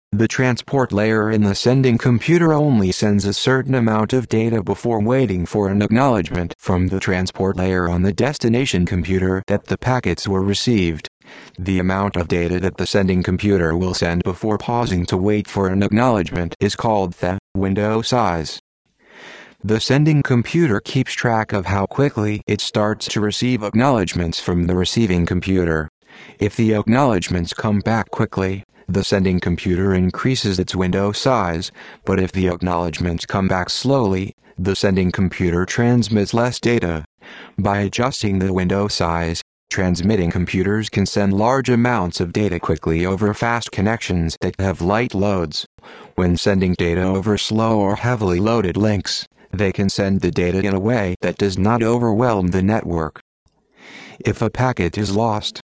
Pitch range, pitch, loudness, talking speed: 90-115 Hz, 100 Hz, -19 LUFS, 155 wpm